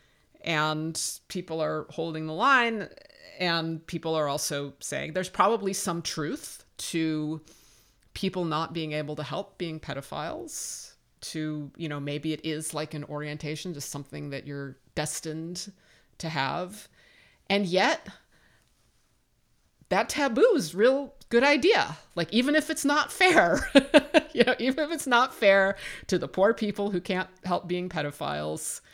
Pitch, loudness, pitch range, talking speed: 170 Hz, -27 LUFS, 150-215 Hz, 145 wpm